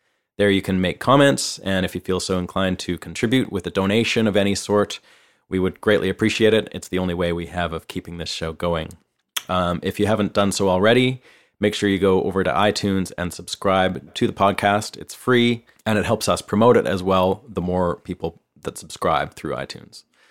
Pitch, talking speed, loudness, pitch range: 95 Hz, 210 wpm, -21 LUFS, 90-105 Hz